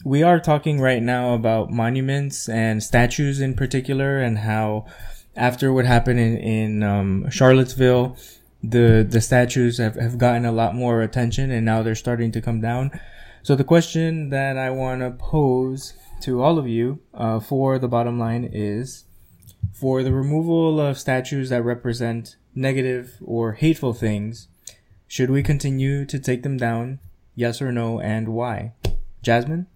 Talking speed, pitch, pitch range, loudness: 160 wpm, 120 Hz, 115-135 Hz, -21 LUFS